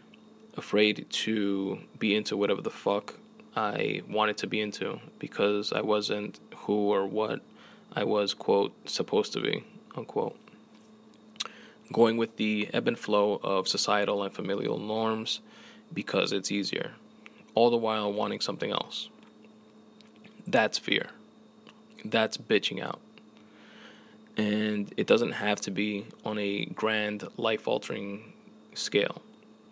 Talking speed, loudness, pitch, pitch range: 125 wpm, -29 LUFS, 105 Hz, 100-110 Hz